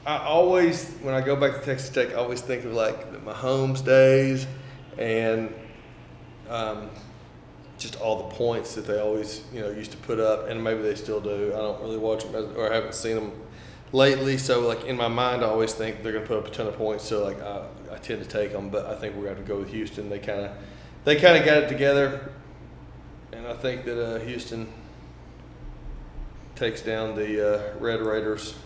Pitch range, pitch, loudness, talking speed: 105-130 Hz, 110 Hz, -25 LUFS, 215 wpm